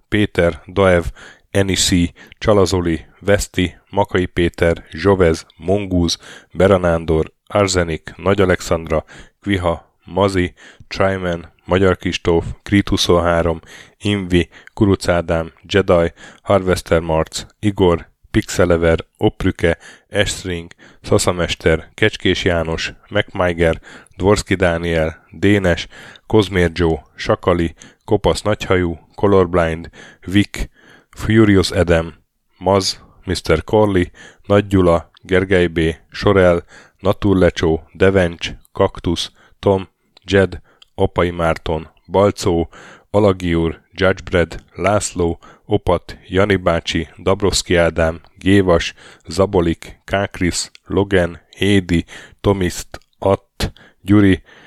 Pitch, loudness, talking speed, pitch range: 90 Hz, -17 LUFS, 85 wpm, 85-95 Hz